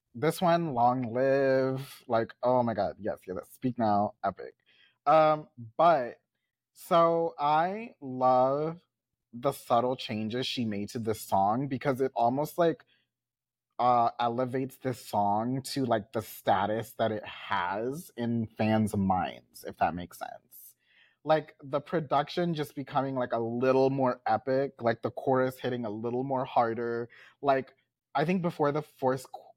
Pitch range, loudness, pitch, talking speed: 115-140 Hz, -29 LUFS, 130 Hz, 145 wpm